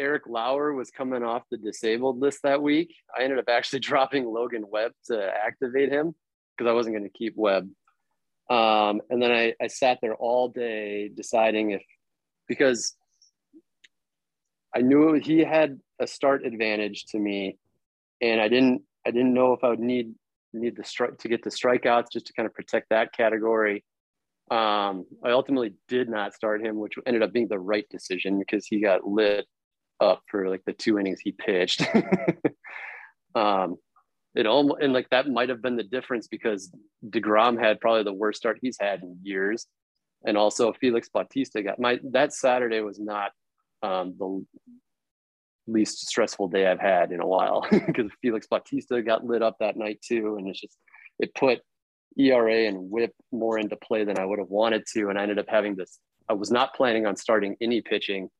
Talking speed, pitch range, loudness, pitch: 185 wpm, 105-125 Hz, -25 LUFS, 115 Hz